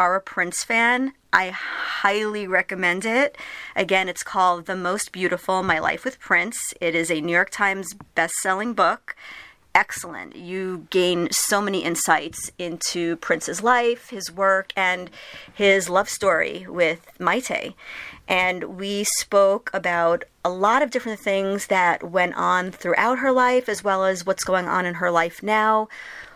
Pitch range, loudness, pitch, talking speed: 180-210 Hz, -22 LUFS, 190 Hz, 155 wpm